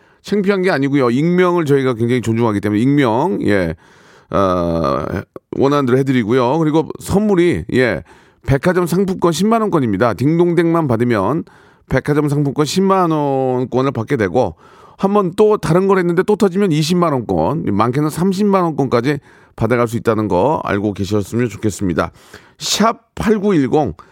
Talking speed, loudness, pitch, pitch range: 305 characters per minute, -16 LUFS, 145 Hz, 120-180 Hz